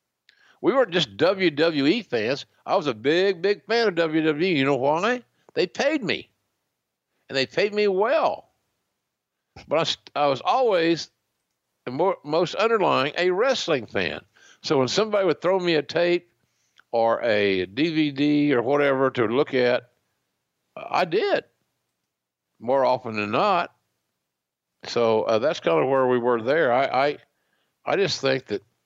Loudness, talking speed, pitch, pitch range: -23 LUFS, 150 wpm, 155 Hz, 130-190 Hz